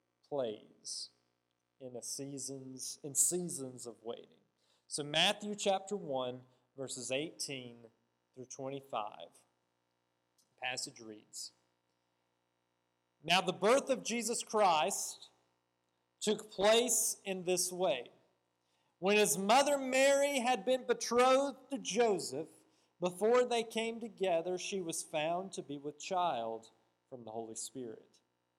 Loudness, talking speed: -34 LUFS, 110 wpm